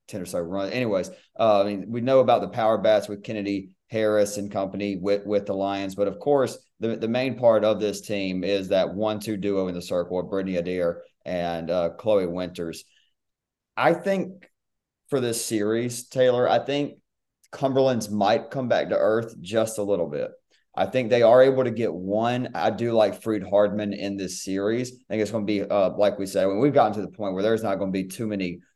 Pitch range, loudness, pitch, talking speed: 95-120 Hz, -24 LUFS, 105 Hz, 220 wpm